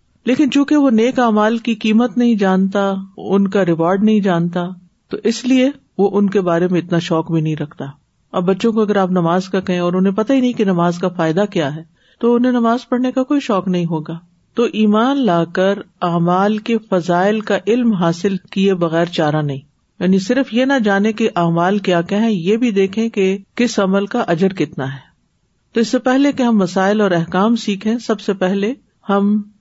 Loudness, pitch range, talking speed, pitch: -16 LUFS, 180-230 Hz, 205 wpm, 200 Hz